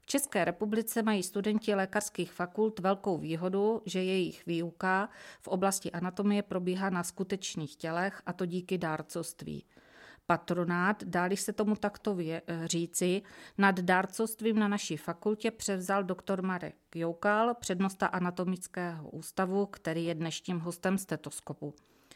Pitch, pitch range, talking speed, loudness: 185 Hz, 170-205 Hz, 125 wpm, -33 LUFS